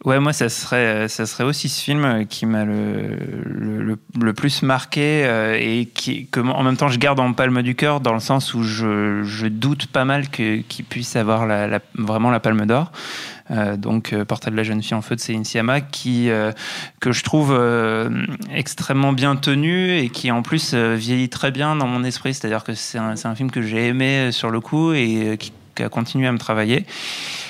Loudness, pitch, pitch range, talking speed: -20 LUFS, 120 Hz, 110-135 Hz, 225 wpm